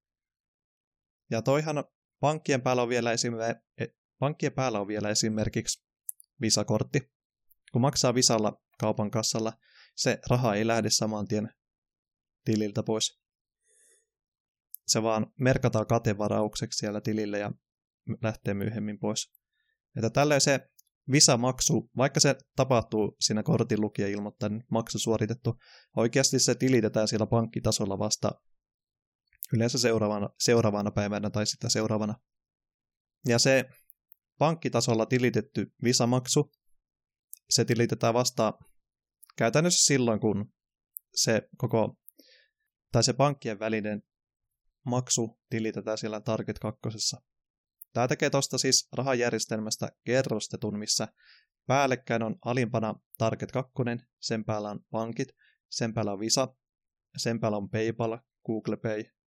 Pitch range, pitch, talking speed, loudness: 110-130 Hz, 115 Hz, 110 wpm, -28 LUFS